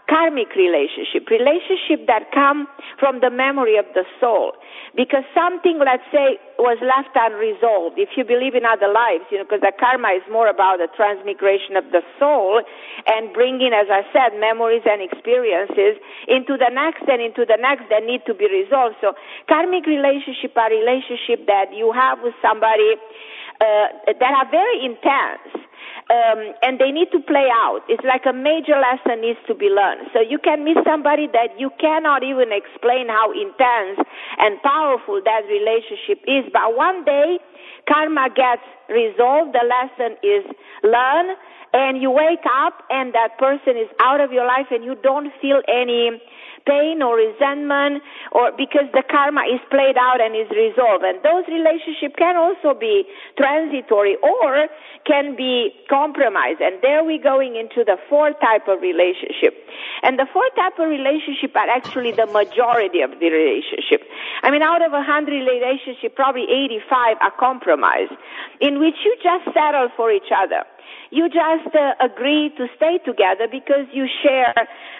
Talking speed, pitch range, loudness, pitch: 165 wpm, 235-310 Hz, -17 LUFS, 270 Hz